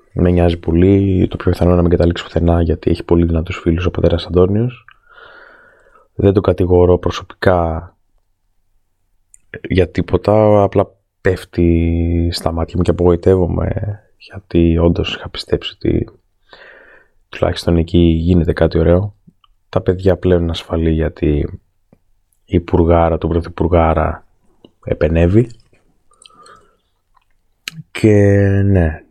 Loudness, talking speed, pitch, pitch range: -15 LUFS, 110 wpm, 90 Hz, 85-100 Hz